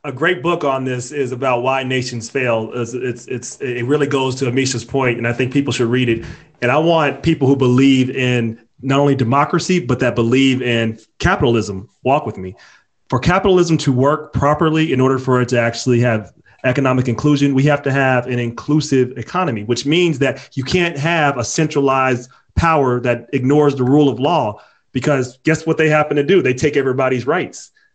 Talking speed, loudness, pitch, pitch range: 195 wpm, -16 LUFS, 130 Hz, 125-145 Hz